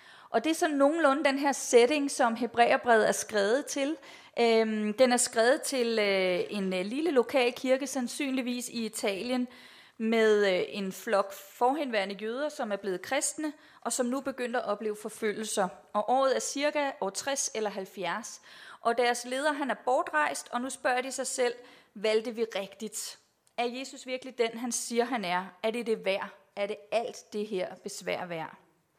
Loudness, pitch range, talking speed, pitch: -29 LUFS, 210-265 Hz, 170 wpm, 240 Hz